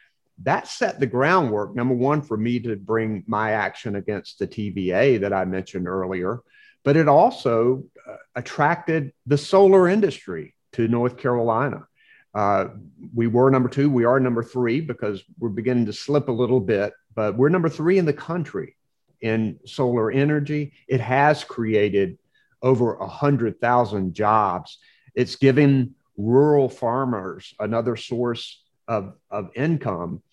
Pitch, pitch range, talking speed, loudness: 125 Hz, 110-145 Hz, 145 wpm, -22 LUFS